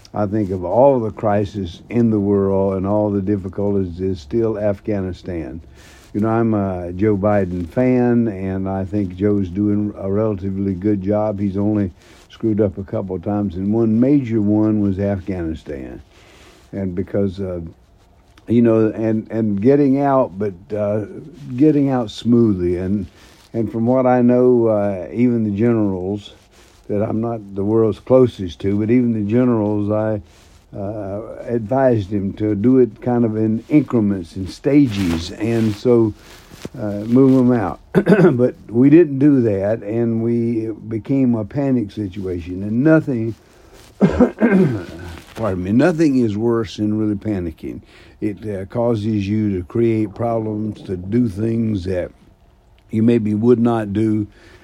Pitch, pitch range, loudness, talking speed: 105 Hz, 100-115 Hz, -18 LUFS, 155 wpm